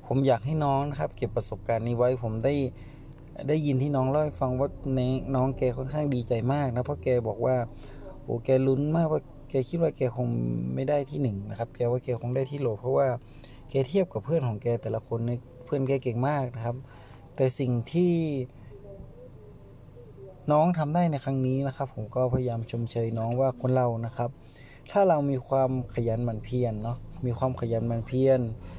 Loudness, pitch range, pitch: -28 LUFS, 120-135 Hz, 130 Hz